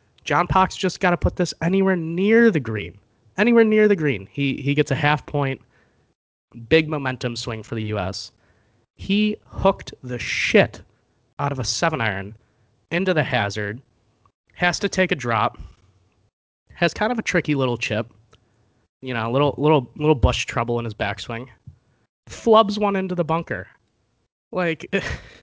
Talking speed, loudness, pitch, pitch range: 160 wpm, -21 LUFS, 130 Hz, 110-175 Hz